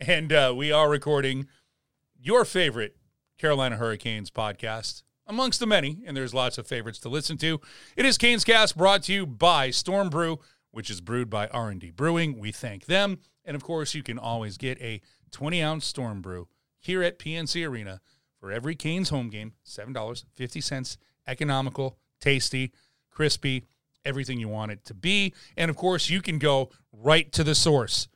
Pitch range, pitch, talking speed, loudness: 120-160 Hz, 140 Hz, 180 wpm, -26 LUFS